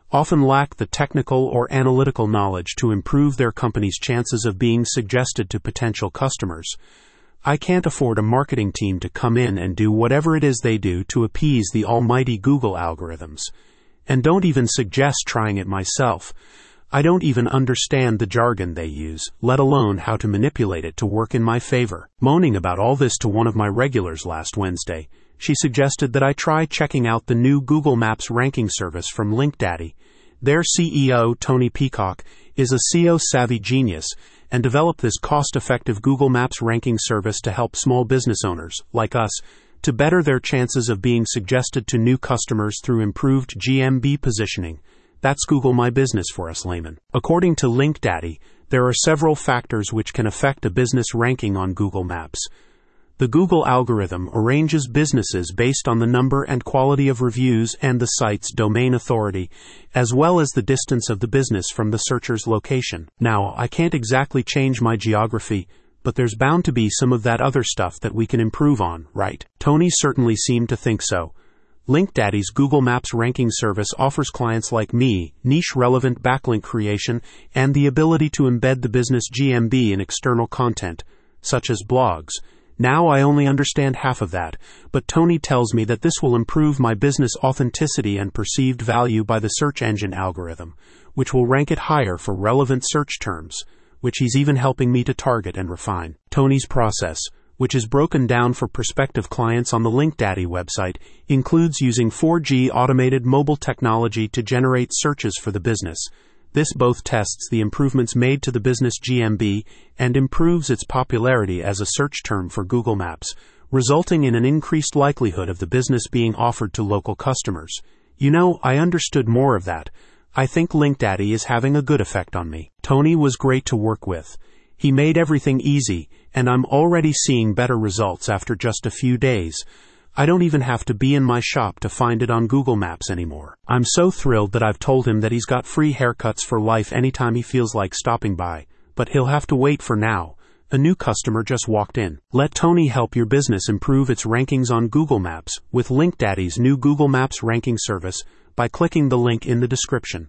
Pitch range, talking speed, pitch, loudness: 110-135 Hz, 180 wpm, 125 Hz, -19 LUFS